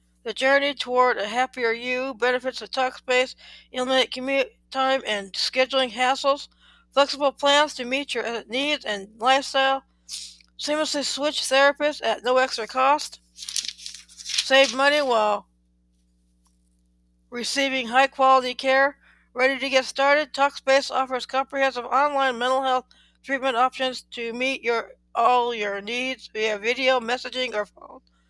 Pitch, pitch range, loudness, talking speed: 255 Hz, 225-270 Hz, -23 LUFS, 125 wpm